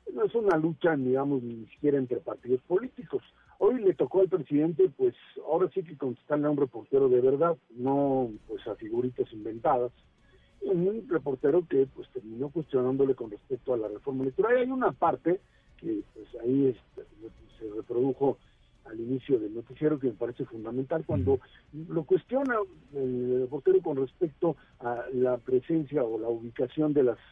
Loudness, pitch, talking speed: -29 LUFS, 150 Hz, 165 wpm